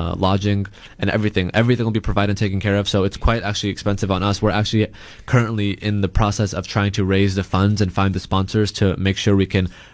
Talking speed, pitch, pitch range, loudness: 240 wpm, 100 Hz, 95-105 Hz, -19 LUFS